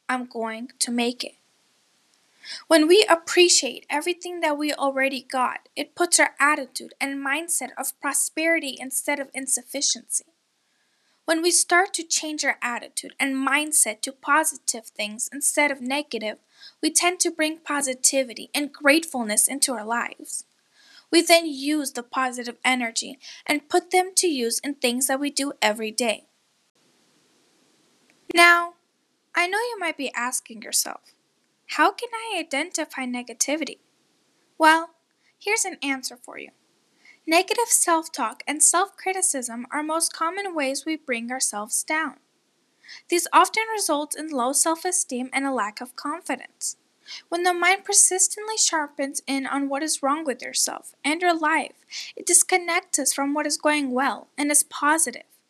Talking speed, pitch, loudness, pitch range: 150 wpm, 295 Hz, -22 LUFS, 265-335 Hz